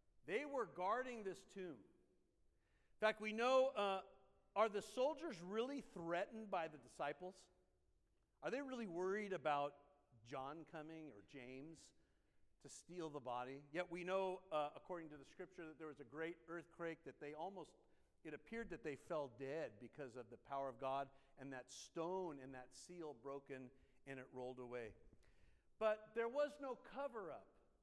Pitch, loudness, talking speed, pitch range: 160 Hz, -47 LUFS, 165 wpm, 135-195 Hz